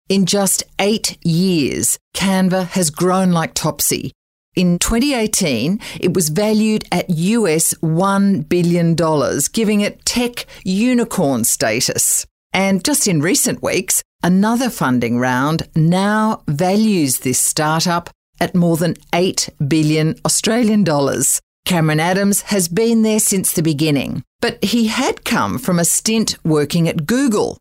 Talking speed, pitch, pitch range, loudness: 130 wpm, 185 Hz, 165-215 Hz, -16 LUFS